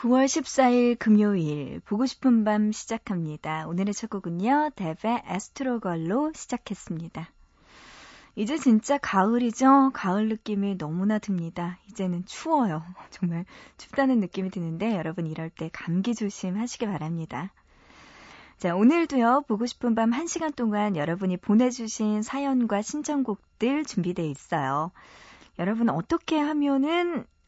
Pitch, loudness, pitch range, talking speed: 215 Hz, -26 LUFS, 180-255 Hz, 290 characters per minute